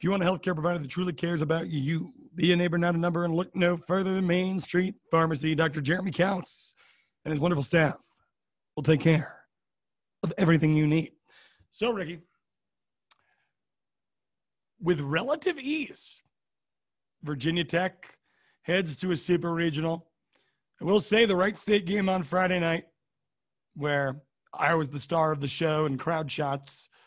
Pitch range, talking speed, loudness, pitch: 155-185 Hz, 160 wpm, -27 LUFS, 170 Hz